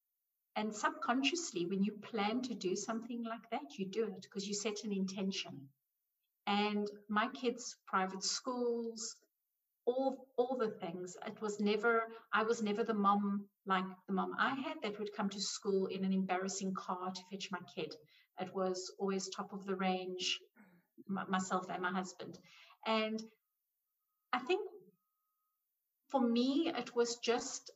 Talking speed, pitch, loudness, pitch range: 155 wpm, 210 Hz, -38 LUFS, 190-235 Hz